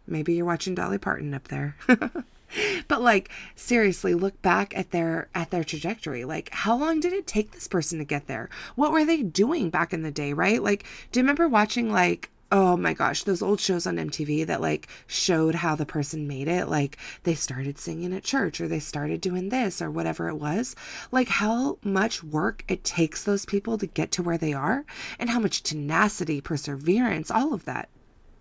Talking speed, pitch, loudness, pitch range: 205 wpm, 180 Hz, -26 LUFS, 155-220 Hz